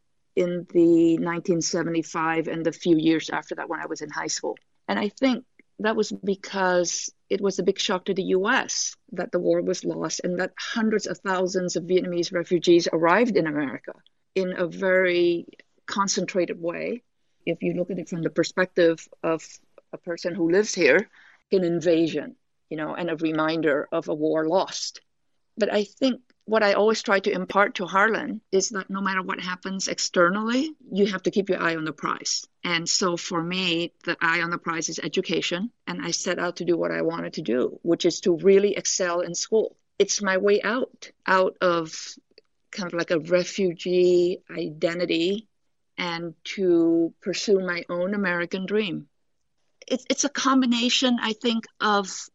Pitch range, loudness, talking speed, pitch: 170-200 Hz, -24 LUFS, 180 wpm, 180 Hz